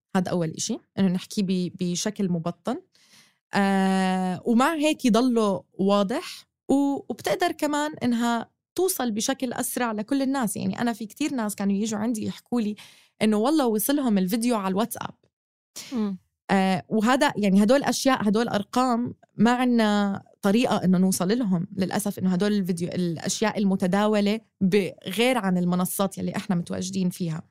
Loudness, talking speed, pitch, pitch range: -24 LUFS, 135 wpm, 210 Hz, 190-240 Hz